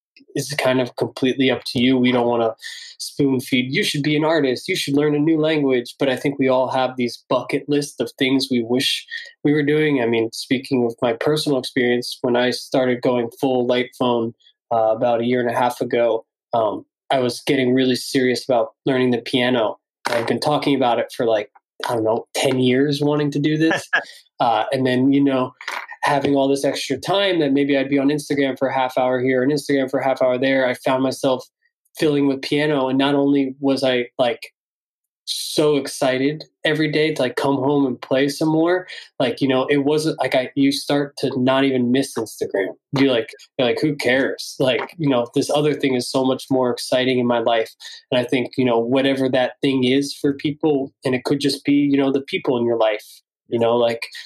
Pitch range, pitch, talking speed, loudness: 125-145 Hz, 135 Hz, 220 wpm, -19 LUFS